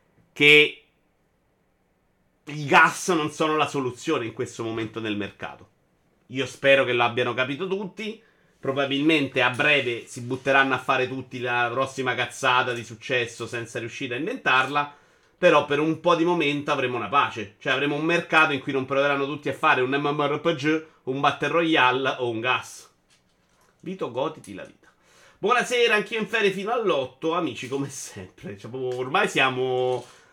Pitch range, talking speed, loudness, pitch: 125-155 Hz, 155 wpm, -23 LUFS, 140 Hz